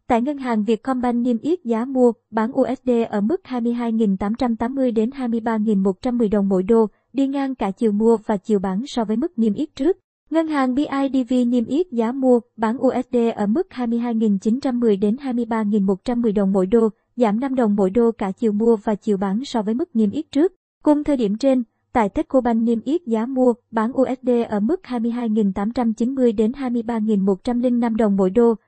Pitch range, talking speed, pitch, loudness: 220-255 Hz, 180 wpm, 235 Hz, -20 LUFS